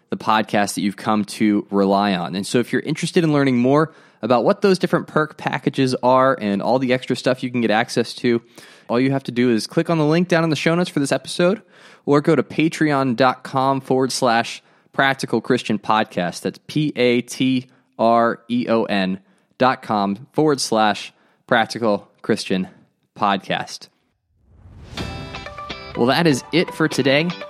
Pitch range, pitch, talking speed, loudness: 115-150 Hz, 130 Hz, 165 wpm, -19 LUFS